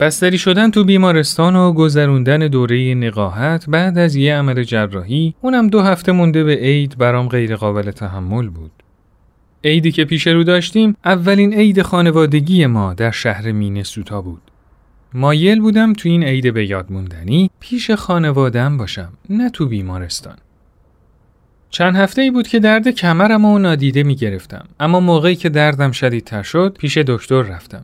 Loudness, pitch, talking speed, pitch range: -14 LUFS, 150 Hz, 155 wpm, 115-180 Hz